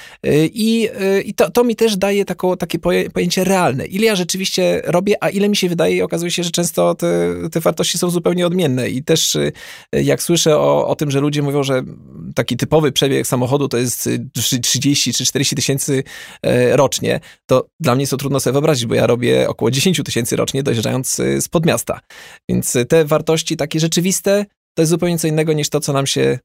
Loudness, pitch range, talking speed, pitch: -16 LUFS, 130-175 Hz, 195 wpm, 150 Hz